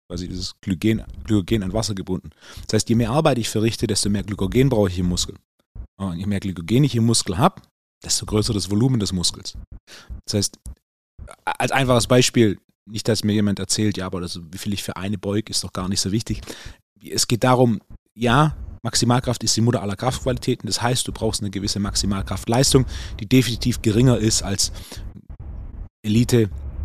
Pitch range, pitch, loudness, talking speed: 95-115 Hz, 105 Hz, -21 LUFS, 185 wpm